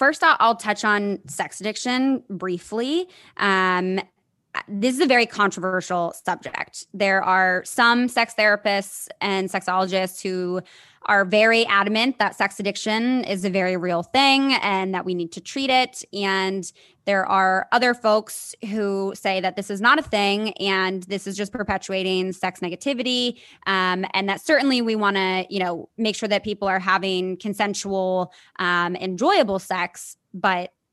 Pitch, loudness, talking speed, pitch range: 200 Hz, -21 LUFS, 155 wpm, 185-220 Hz